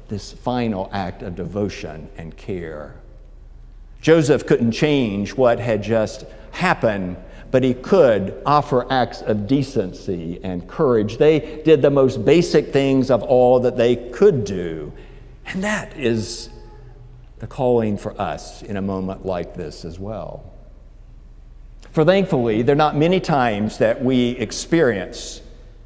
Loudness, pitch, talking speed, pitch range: -19 LUFS, 115 Hz, 135 wpm, 100-135 Hz